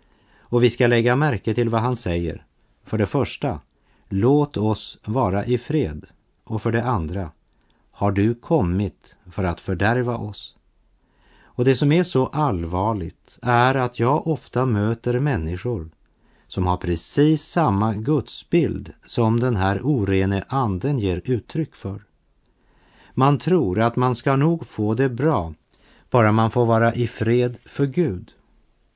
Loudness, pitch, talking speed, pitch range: -21 LUFS, 115 Hz, 145 wpm, 100-130 Hz